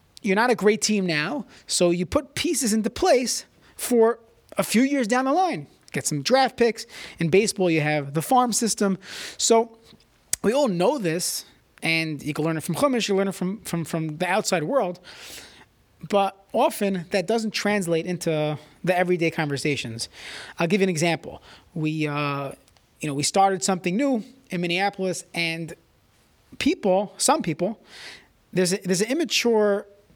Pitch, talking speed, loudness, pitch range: 190 Hz, 165 wpm, -23 LUFS, 165-225 Hz